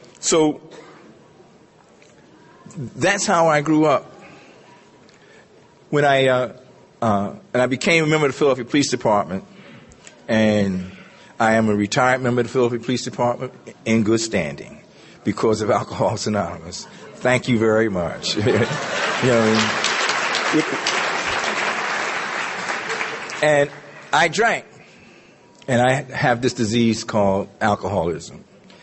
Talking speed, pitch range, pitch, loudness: 115 wpm, 110-140 Hz, 120 Hz, -19 LUFS